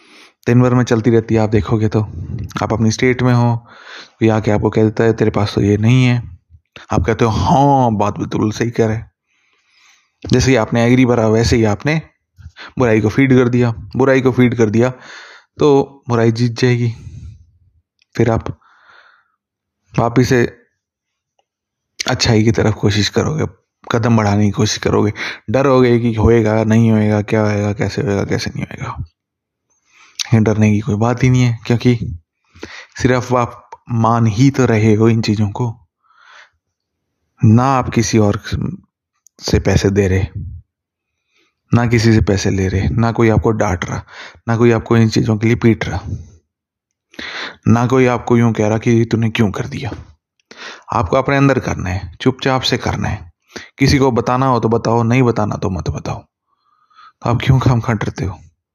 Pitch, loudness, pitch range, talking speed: 115 Hz, -15 LUFS, 105-125 Hz, 170 wpm